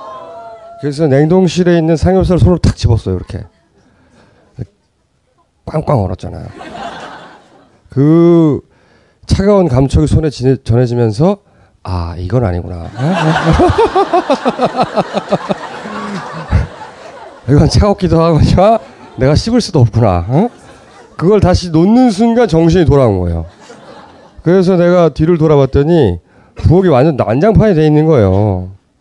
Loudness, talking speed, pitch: -11 LUFS, 235 characters per minute, 150 Hz